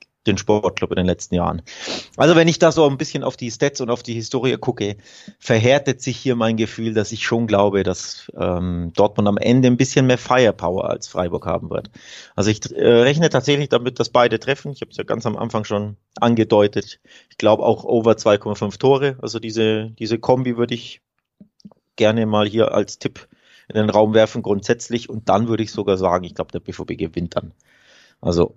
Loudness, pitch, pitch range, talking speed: -19 LUFS, 115 Hz, 105-130 Hz, 200 wpm